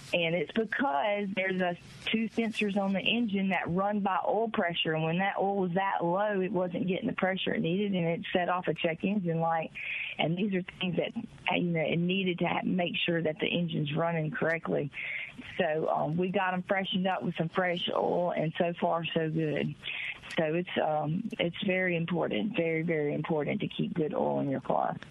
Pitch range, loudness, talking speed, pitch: 165-200 Hz, -30 LUFS, 210 wpm, 180 Hz